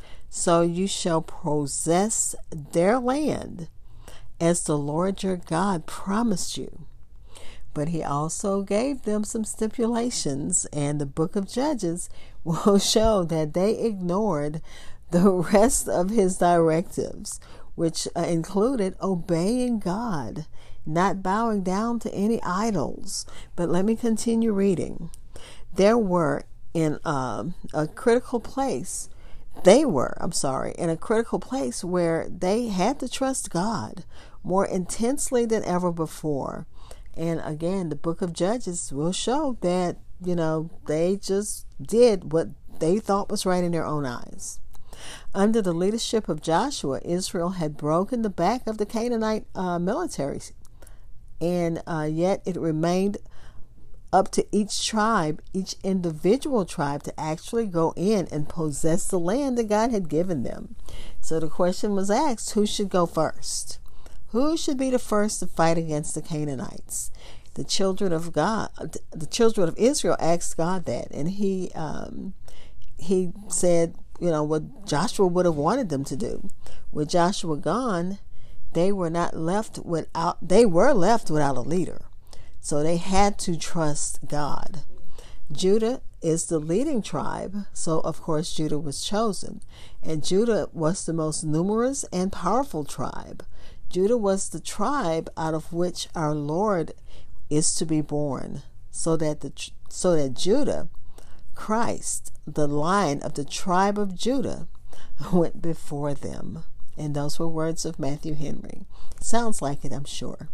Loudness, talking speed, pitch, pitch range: -25 LUFS, 145 wpm, 175 Hz, 160-210 Hz